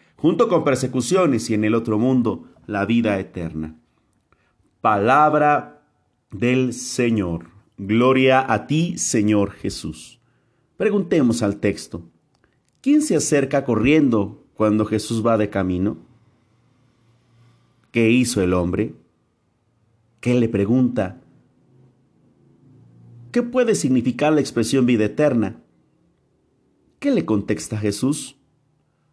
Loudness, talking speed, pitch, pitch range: -20 LUFS, 100 wpm, 115 Hz, 105-130 Hz